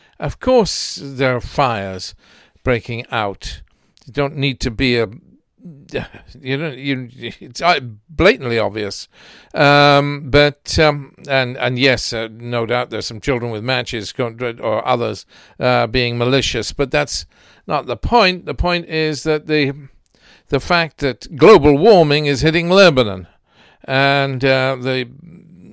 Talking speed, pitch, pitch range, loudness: 140 wpm, 135 Hz, 120-150 Hz, -16 LUFS